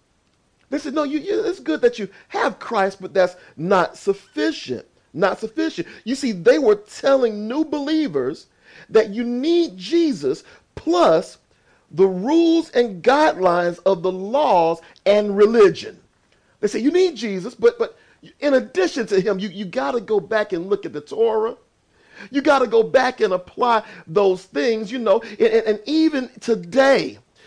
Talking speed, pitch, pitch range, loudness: 165 wpm, 245 Hz, 205-320 Hz, -20 LUFS